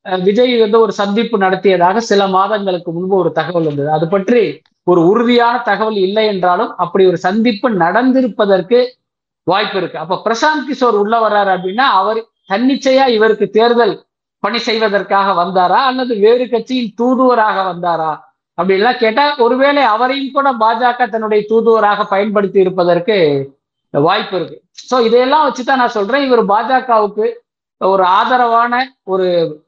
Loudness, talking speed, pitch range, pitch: -13 LUFS, 130 wpm, 190-245 Hz, 220 Hz